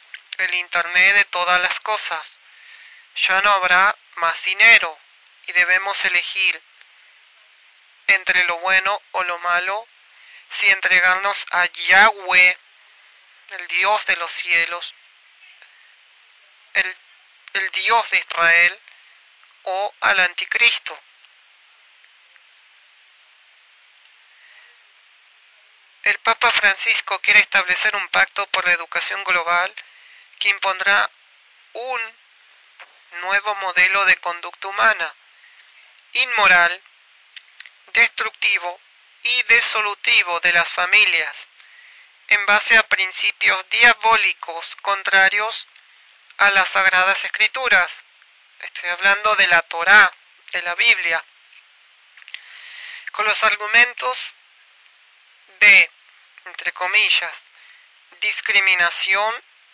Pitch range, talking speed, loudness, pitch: 180-220 Hz, 90 wpm, -16 LUFS, 195 Hz